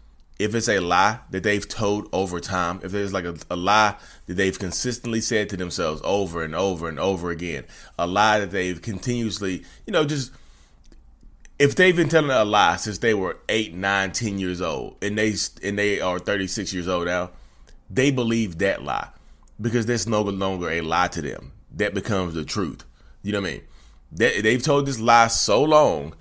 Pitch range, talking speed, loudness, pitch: 90-115 Hz, 195 wpm, -22 LUFS, 100 Hz